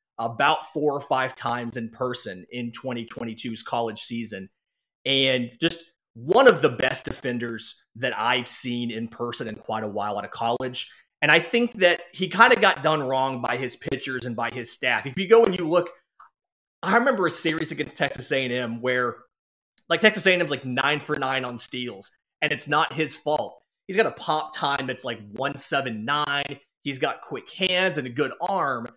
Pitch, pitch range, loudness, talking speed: 130 Hz, 120-160 Hz, -24 LUFS, 190 wpm